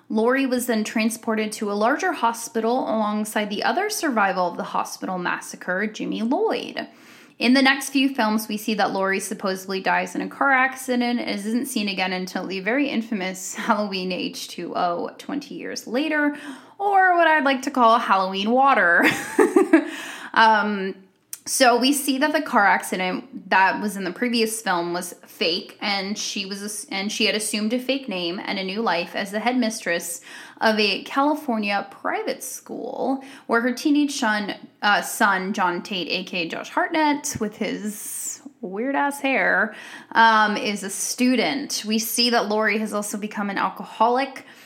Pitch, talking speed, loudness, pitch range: 230 Hz, 165 wpm, -22 LUFS, 205-270 Hz